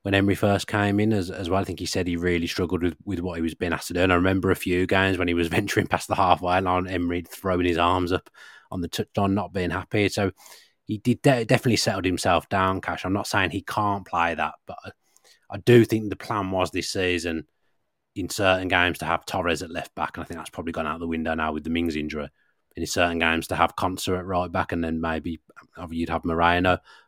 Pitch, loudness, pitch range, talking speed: 90 Hz, -24 LUFS, 85-100 Hz, 250 wpm